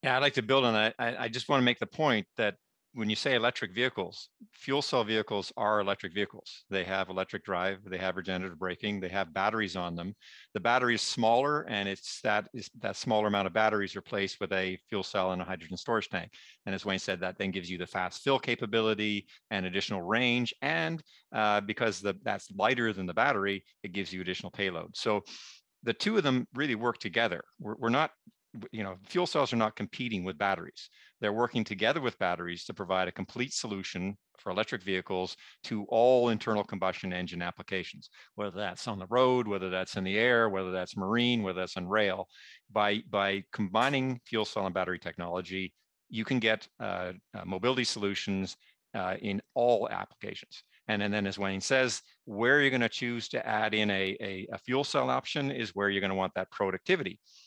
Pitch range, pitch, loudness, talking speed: 95-115 Hz, 105 Hz, -31 LUFS, 205 wpm